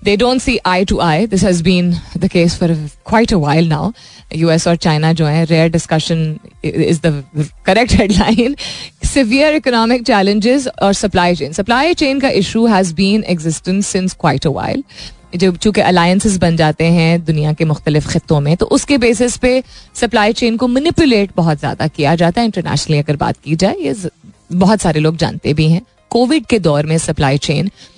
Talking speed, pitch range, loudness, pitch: 180 wpm, 160-220 Hz, -13 LUFS, 180 Hz